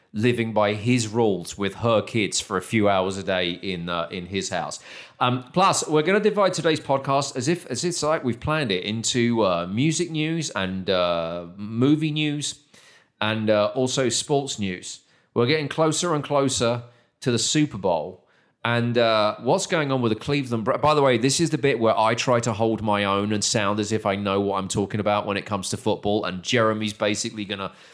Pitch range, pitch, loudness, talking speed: 100-140 Hz, 115 Hz, -23 LUFS, 210 wpm